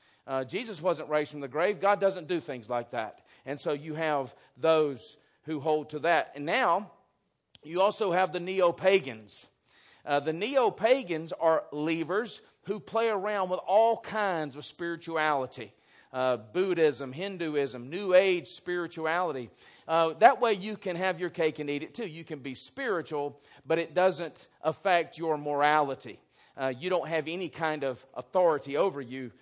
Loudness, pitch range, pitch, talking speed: -29 LUFS, 145-185 Hz, 160 Hz, 165 wpm